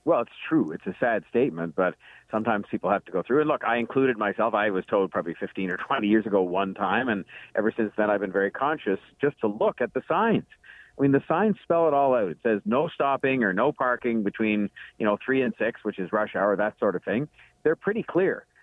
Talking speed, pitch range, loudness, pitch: 245 wpm, 105-135 Hz, -26 LUFS, 110 Hz